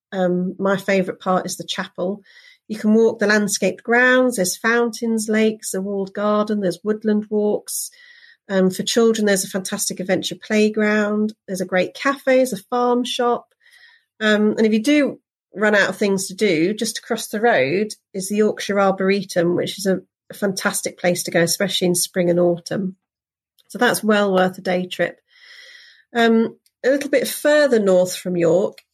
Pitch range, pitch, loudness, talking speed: 185-230 Hz, 210 Hz, -19 LUFS, 175 wpm